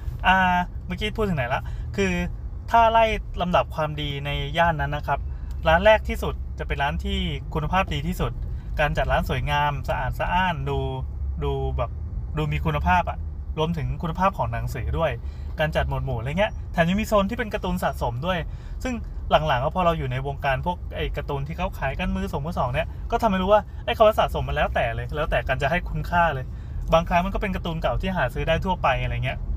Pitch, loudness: 145 Hz, -24 LUFS